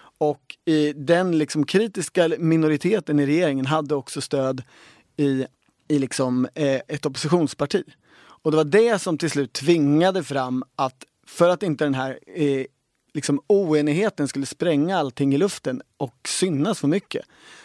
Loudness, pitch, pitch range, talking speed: -22 LUFS, 150 Hz, 140-160 Hz, 145 wpm